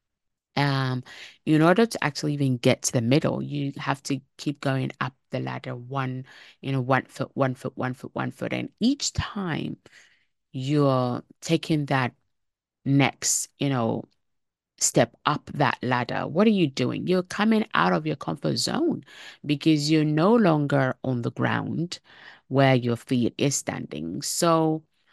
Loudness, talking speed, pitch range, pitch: -25 LUFS, 160 wpm, 125-155 Hz, 135 Hz